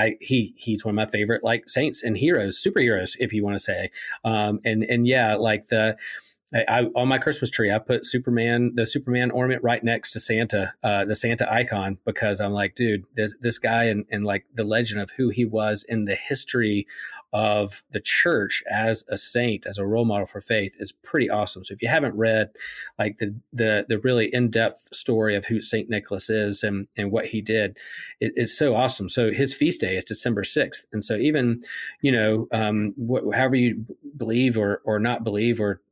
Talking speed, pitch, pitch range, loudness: 210 wpm, 110 Hz, 105-120 Hz, -23 LUFS